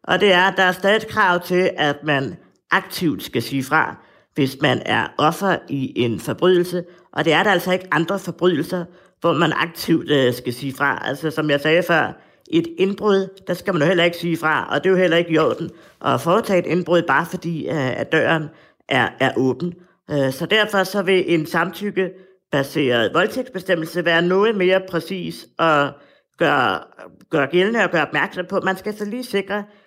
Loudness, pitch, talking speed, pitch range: -19 LUFS, 175 Hz, 190 wpm, 155-190 Hz